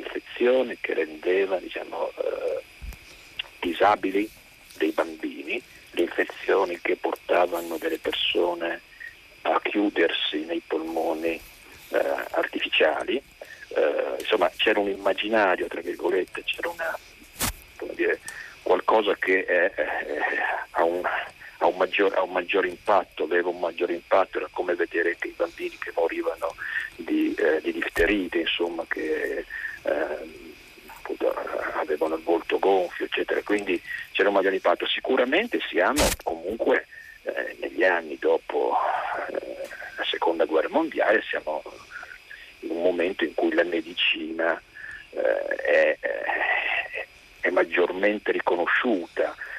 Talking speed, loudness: 105 wpm, -25 LUFS